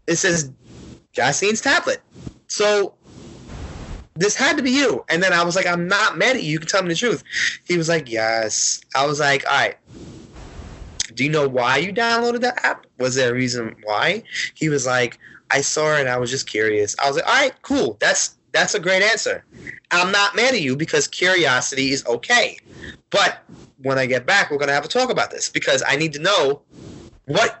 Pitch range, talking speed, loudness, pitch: 125-195 Hz, 210 wpm, -19 LUFS, 150 Hz